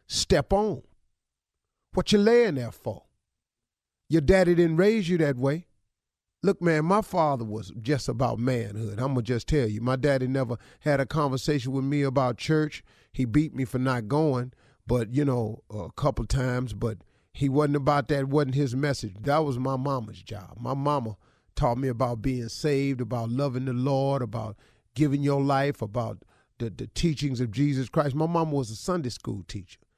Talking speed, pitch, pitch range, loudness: 185 wpm, 135 Hz, 120-150 Hz, -26 LUFS